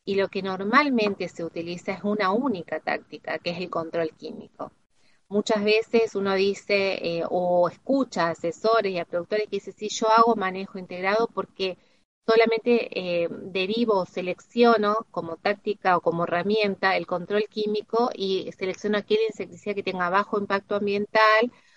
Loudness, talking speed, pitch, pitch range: -25 LUFS, 155 wpm, 200 Hz, 180-220 Hz